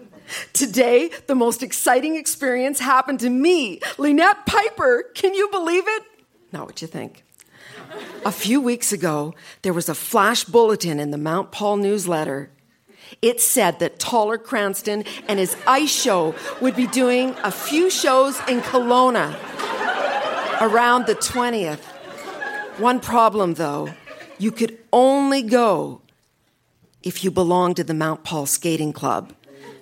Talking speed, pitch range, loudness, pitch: 135 wpm, 185-265 Hz, -19 LUFS, 235 Hz